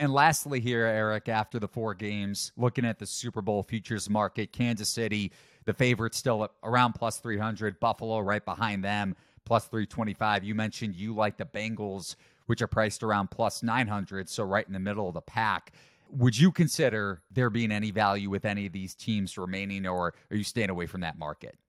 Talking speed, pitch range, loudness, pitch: 195 wpm, 100-115 Hz, -30 LUFS, 110 Hz